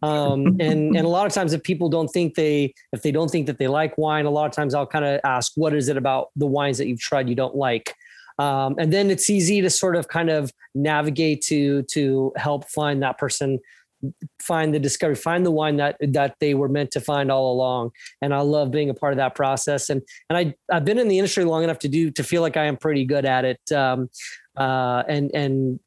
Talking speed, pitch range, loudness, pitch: 245 wpm, 135-160 Hz, -22 LUFS, 145 Hz